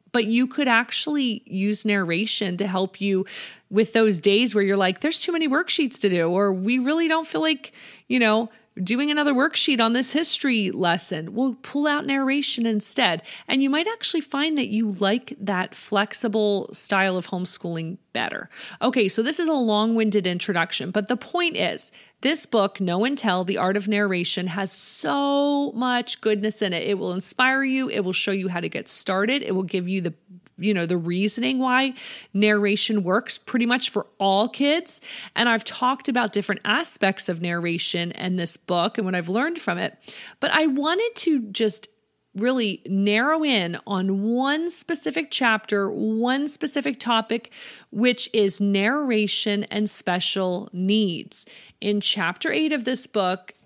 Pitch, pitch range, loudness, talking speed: 215 Hz, 195-260 Hz, -23 LUFS, 170 wpm